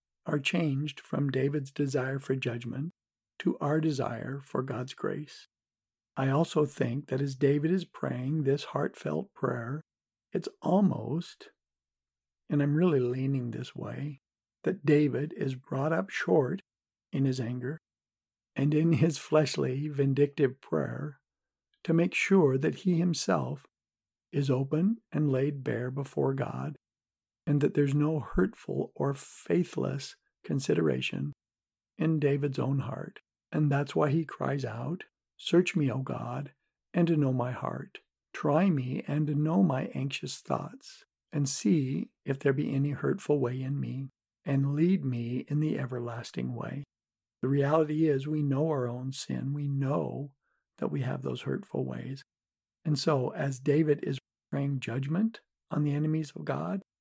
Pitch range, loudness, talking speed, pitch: 130-155 Hz, -30 LUFS, 145 wpm, 140 Hz